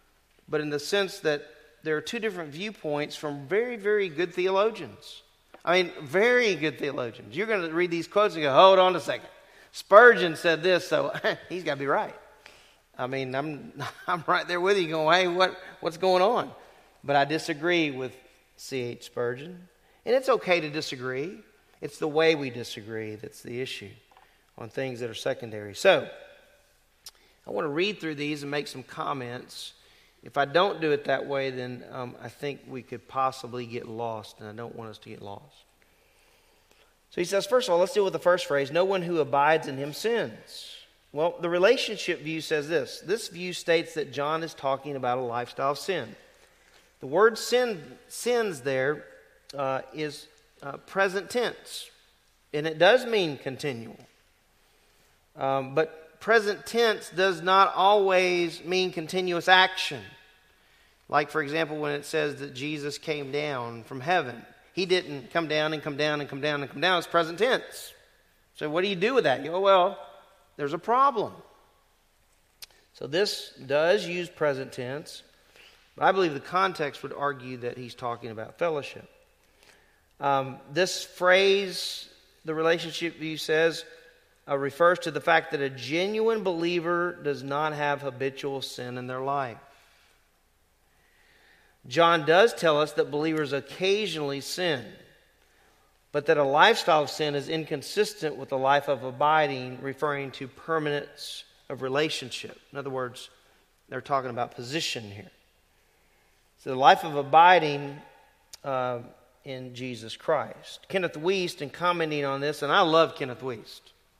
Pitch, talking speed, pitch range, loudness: 150 Hz, 165 wpm, 135-180 Hz, -26 LUFS